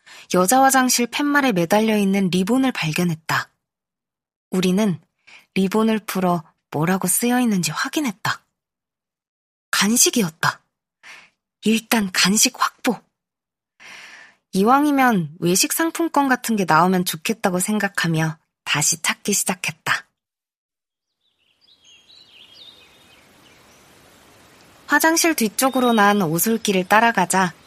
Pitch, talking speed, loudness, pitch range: 205 Hz, 215 characters per minute, -19 LUFS, 180-250 Hz